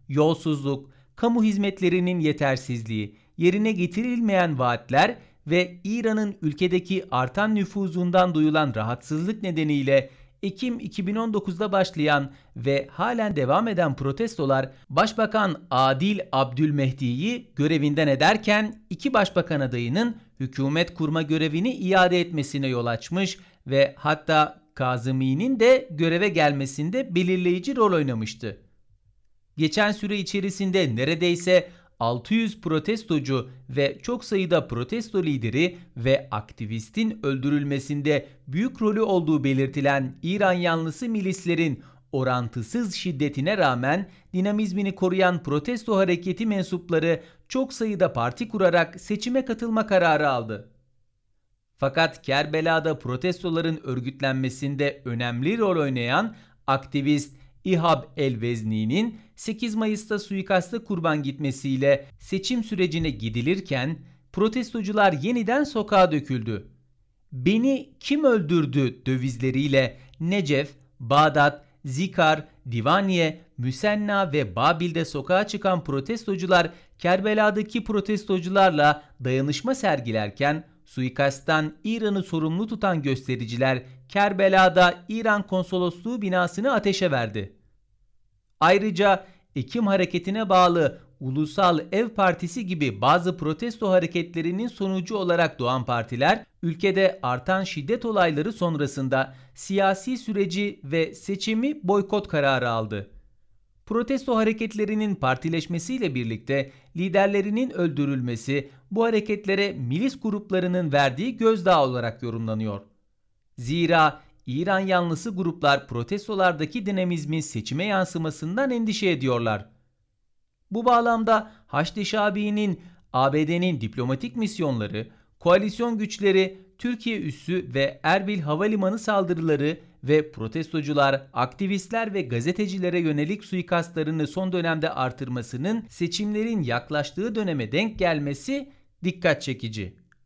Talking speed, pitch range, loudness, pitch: 95 wpm, 135-200 Hz, -24 LUFS, 165 Hz